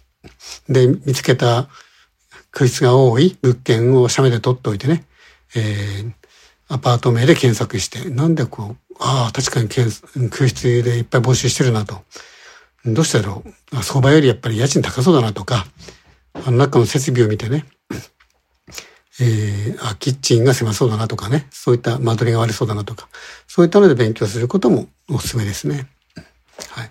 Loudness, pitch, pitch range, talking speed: -17 LUFS, 125 Hz, 115-135 Hz, 325 characters per minute